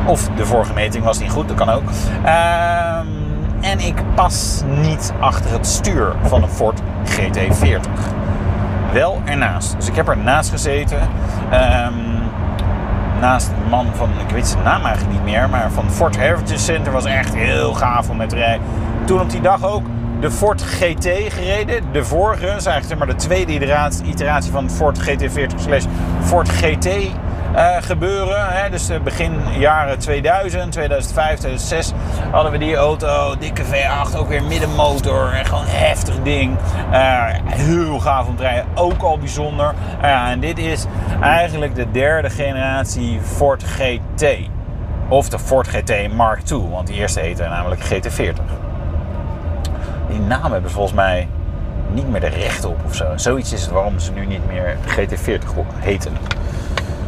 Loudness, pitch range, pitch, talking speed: -17 LUFS, 85-110 Hz, 95 Hz, 160 wpm